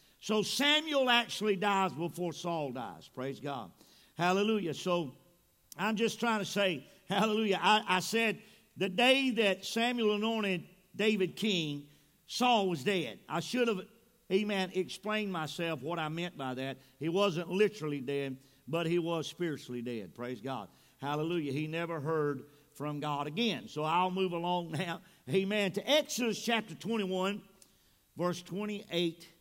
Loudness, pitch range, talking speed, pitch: -33 LUFS, 155-210 Hz, 145 wpm, 180 Hz